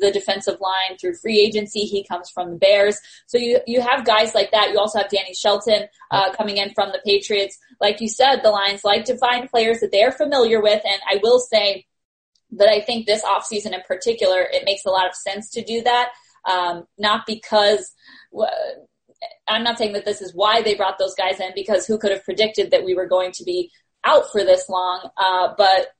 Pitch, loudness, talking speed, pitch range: 210 Hz, -19 LUFS, 215 wpm, 195-230 Hz